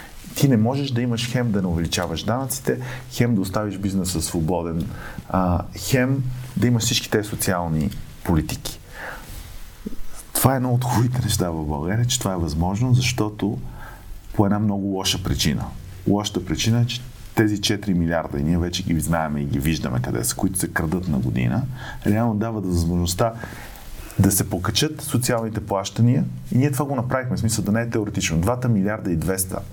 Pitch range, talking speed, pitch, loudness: 90-120 Hz, 175 wpm, 105 Hz, -22 LUFS